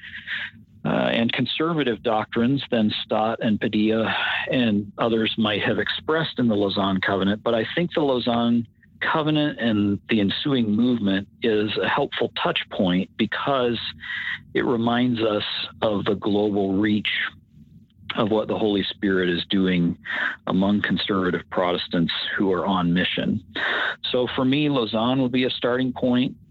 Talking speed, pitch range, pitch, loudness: 145 wpm, 100-125 Hz, 110 Hz, -23 LUFS